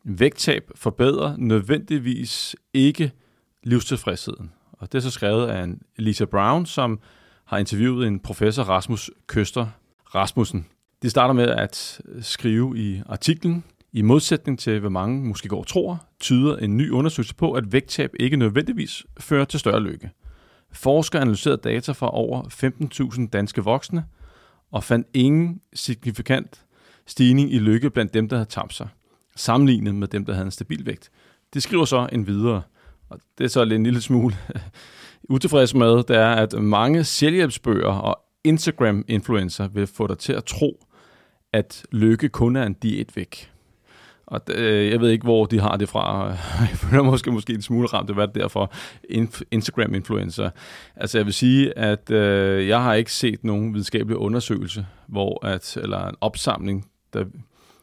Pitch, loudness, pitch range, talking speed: 115 Hz, -22 LUFS, 105-130 Hz, 160 wpm